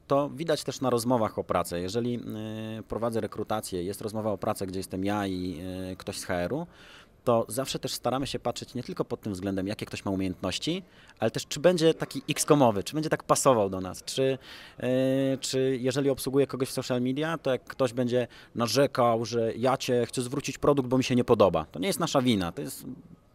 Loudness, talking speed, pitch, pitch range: -28 LUFS, 205 wpm, 125 Hz, 110-135 Hz